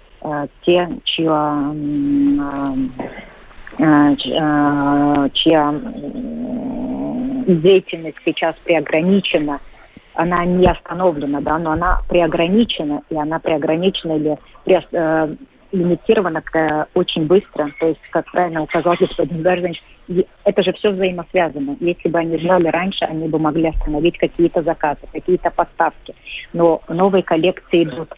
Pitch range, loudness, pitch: 150-180 Hz, -17 LUFS, 165 Hz